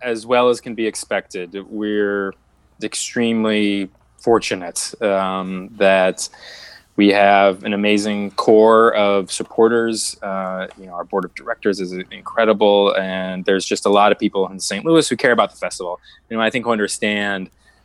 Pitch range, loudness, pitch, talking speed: 95-110 Hz, -18 LUFS, 100 Hz, 165 wpm